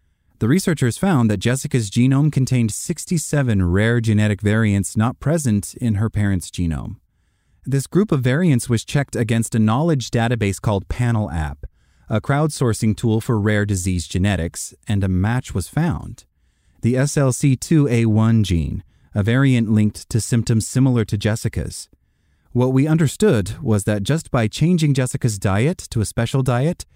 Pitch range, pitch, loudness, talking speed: 105-135 Hz, 115 Hz, -19 LUFS, 145 wpm